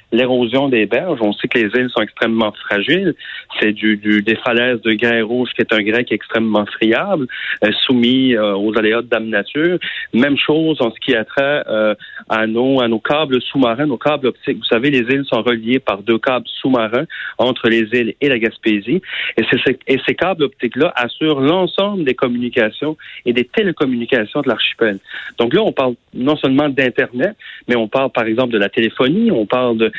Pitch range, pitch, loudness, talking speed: 110-135 Hz, 120 Hz, -16 LUFS, 200 wpm